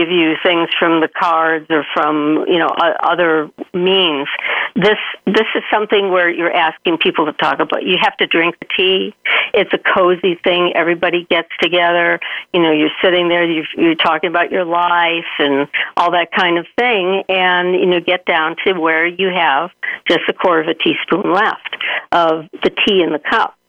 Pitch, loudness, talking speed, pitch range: 175 Hz, -14 LUFS, 190 wpm, 165-185 Hz